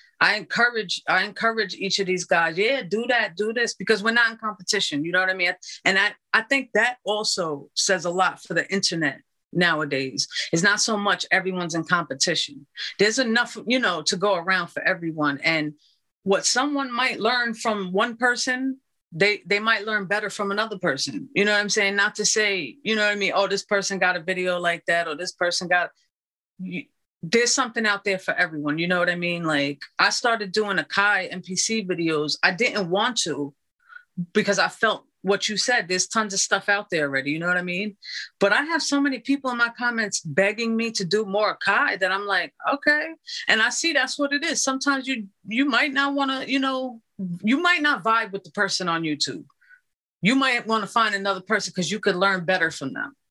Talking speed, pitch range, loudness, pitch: 215 wpm, 180-235 Hz, -22 LUFS, 205 Hz